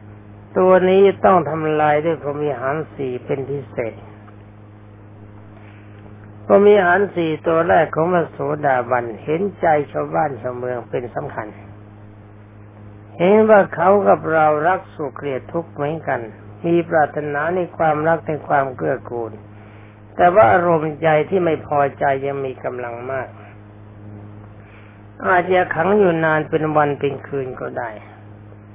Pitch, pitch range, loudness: 135 Hz, 105-160 Hz, -18 LUFS